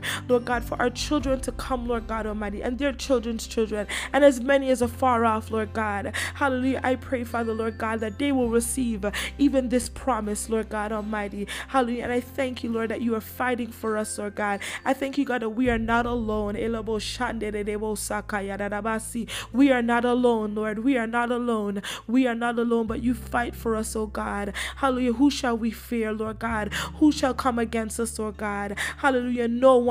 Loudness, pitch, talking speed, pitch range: -25 LUFS, 235 Hz, 200 wpm, 220-255 Hz